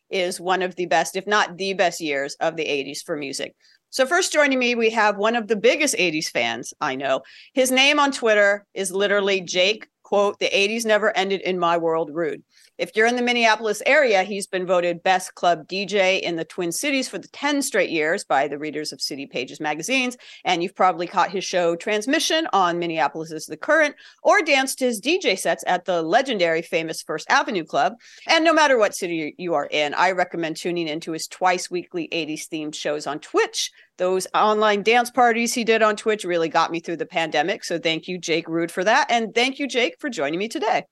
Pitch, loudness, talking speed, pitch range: 185 Hz, -21 LUFS, 210 wpm, 165-235 Hz